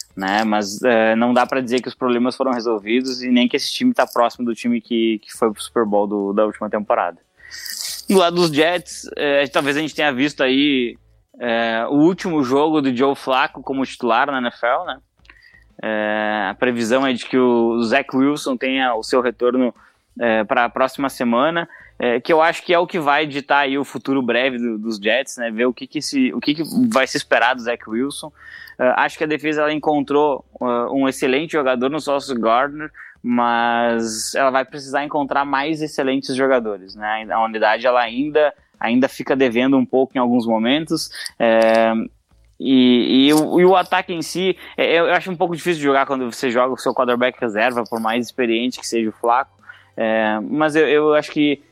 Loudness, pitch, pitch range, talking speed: -18 LUFS, 130 Hz, 120-150 Hz, 205 wpm